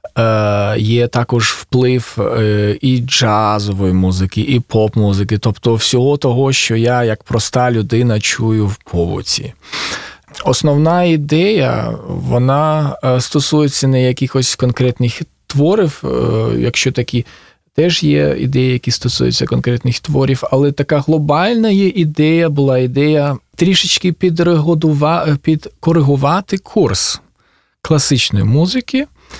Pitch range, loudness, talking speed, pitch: 115-155 Hz, -14 LUFS, 100 wpm, 130 Hz